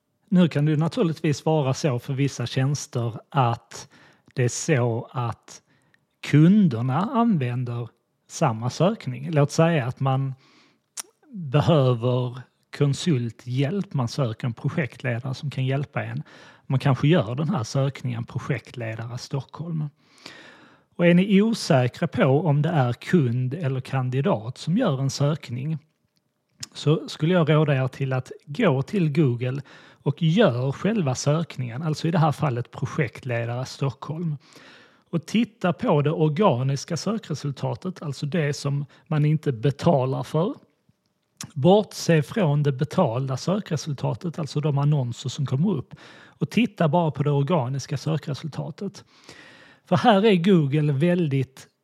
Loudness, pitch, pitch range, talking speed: -24 LUFS, 145 Hz, 130-165 Hz, 130 wpm